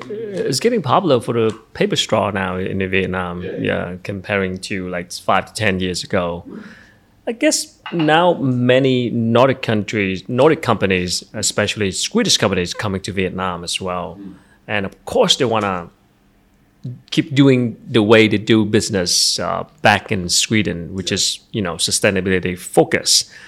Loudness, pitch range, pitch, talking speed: -17 LUFS, 95-115 Hz, 100 Hz, 150 wpm